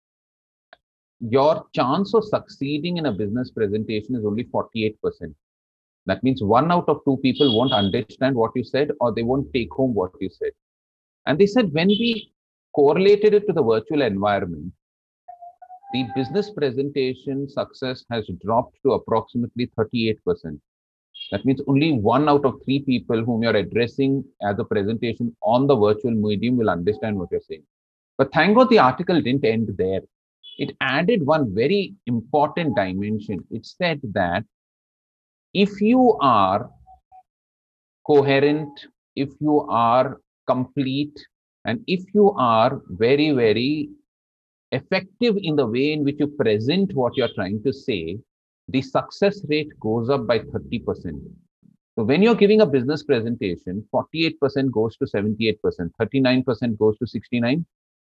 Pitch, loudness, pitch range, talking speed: 135 Hz, -21 LUFS, 115-155 Hz, 145 wpm